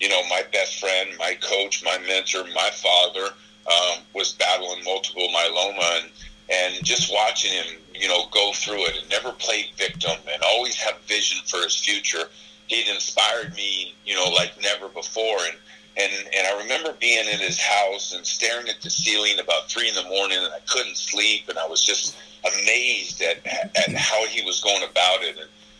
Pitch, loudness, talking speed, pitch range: 100 Hz, -21 LUFS, 190 wpm, 90-105 Hz